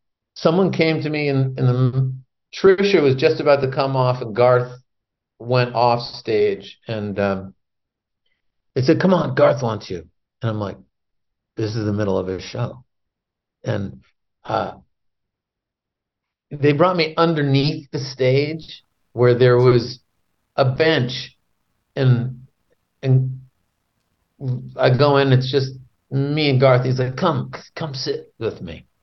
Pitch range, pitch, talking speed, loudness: 115-140 Hz, 130 Hz, 140 wpm, -19 LUFS